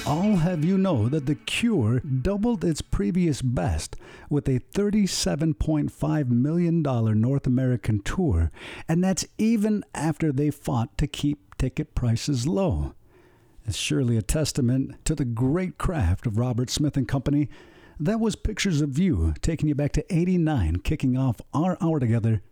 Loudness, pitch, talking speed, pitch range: -25 LUFS, 145 Hz, 165 wpm, 120-165 Hz